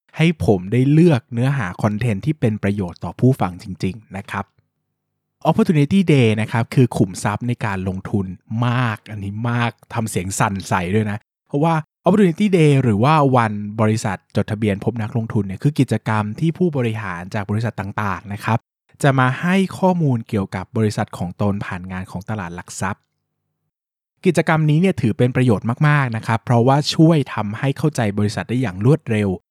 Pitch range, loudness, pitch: 105-135 Hz, -19 LUFS, 115 Hz